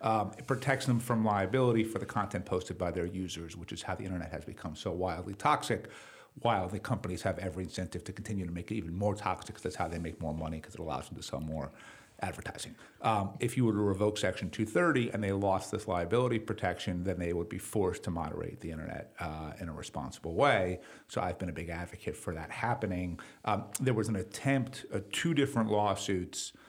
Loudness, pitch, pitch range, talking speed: -34 LUFS, 95 Hz, 90-110 Hz, 225 wpm